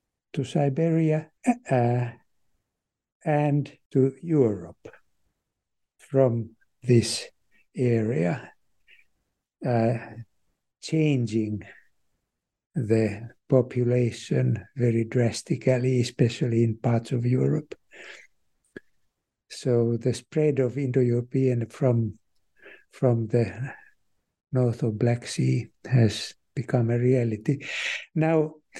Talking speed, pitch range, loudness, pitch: 75 wpm, 115-135 Hz, -25 LUFS, 125 Hz